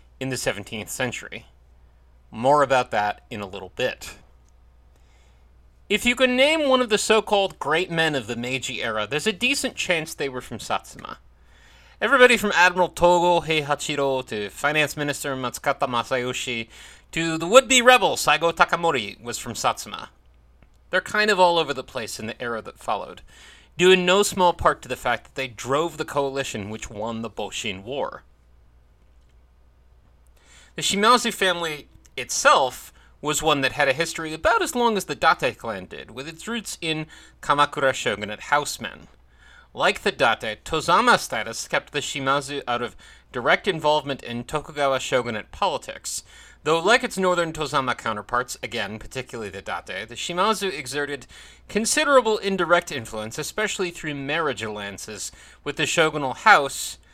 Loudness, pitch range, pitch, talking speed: -22 LUFS, 110-175 Hz, 145 Hz, 155 wpm